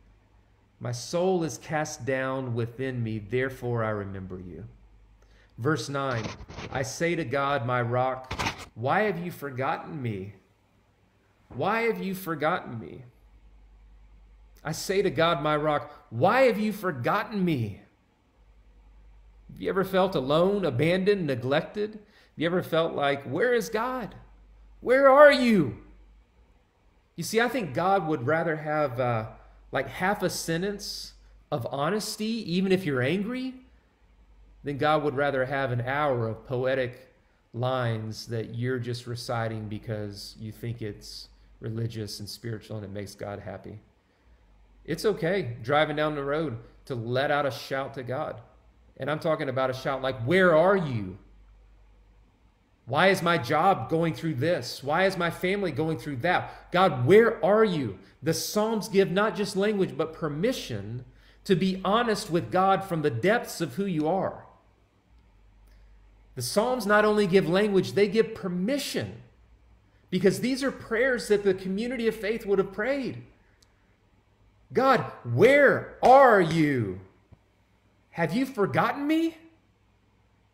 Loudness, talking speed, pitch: -26 LUFS, 145 wpm, 140 Hz